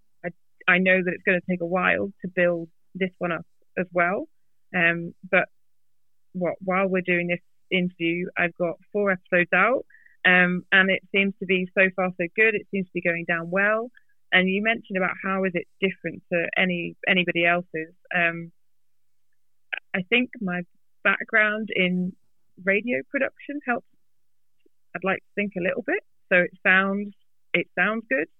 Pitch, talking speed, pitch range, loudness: 185 Hz, 170 wpm, 170-195 Hz, -23 LUFS